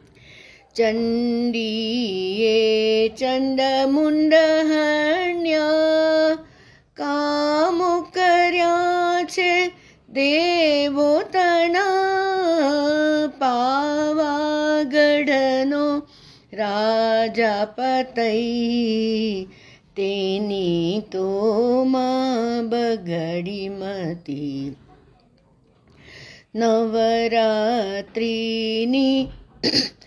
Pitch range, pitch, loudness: 220-305 Hz, 255 Hz, -20 LUFS